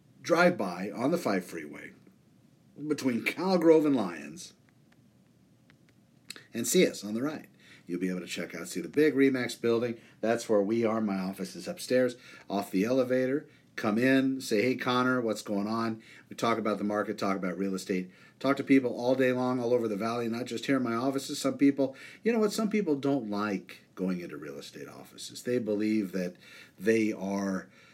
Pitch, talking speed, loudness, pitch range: 115 Hz, 195 wpm, -29 LUFS, 105-135 Hz